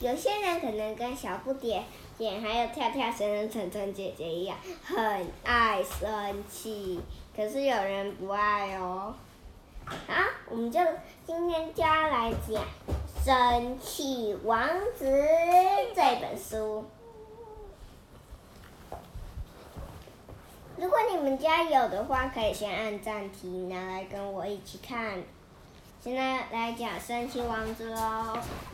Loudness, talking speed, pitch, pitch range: -30 LUFS, 170 characters per minute, 230 Hz, 205-280 Hz